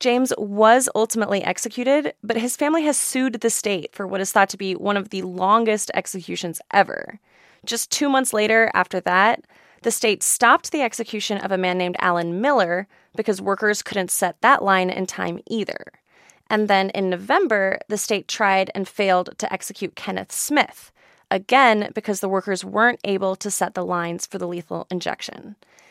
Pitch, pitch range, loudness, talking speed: 200 Hz, 190-230 Hz, -21 LUFS, 175 wpm